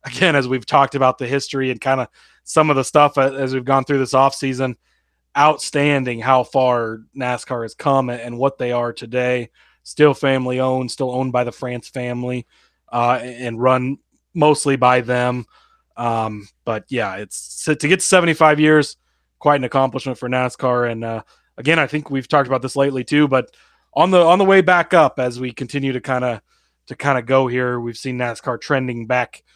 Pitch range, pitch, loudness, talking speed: 125-140 Hz, 130 Hz, -18 LUFS, 195 wpm